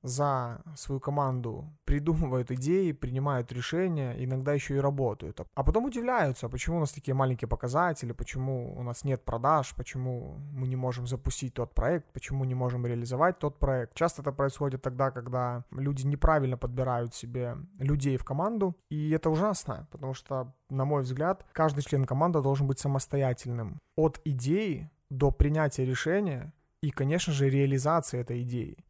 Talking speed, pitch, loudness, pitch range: 155 wpm, 135 Hz, -30 LUFS, 125-155 Hz